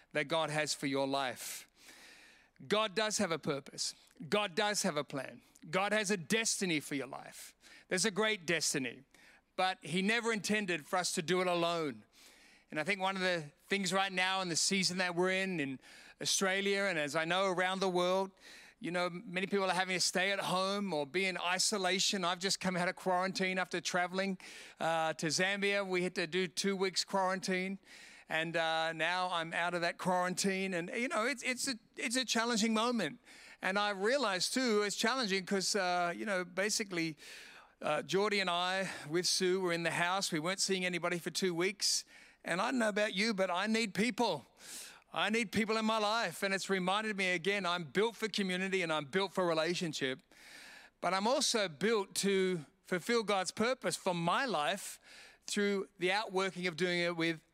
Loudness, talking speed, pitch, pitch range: -34 LUFS, 195 wpm, 185 Hz, 175-205 Hz